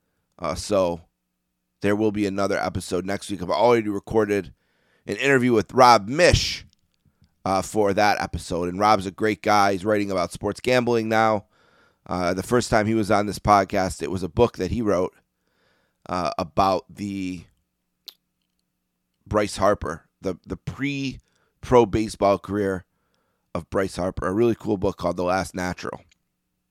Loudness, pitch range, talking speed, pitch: -23 LUFS, 90-110 Hz, 155 wpm, 100 Hz